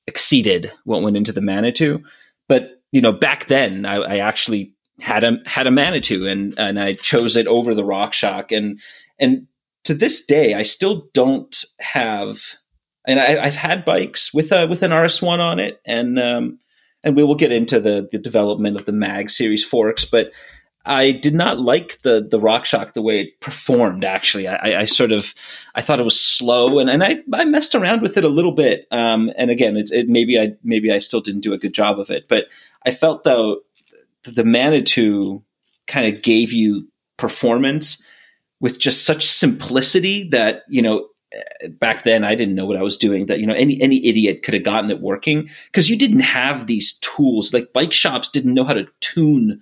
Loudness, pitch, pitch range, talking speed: -16 LUFS, 120 Hz, 105-155 Hz, 200 wpm